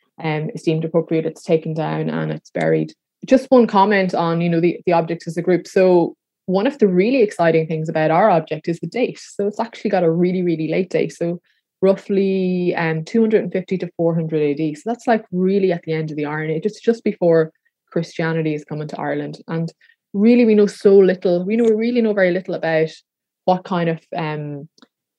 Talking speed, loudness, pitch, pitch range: 220 wpm, -18 LUFS, 175 Hz, 160-200 Hz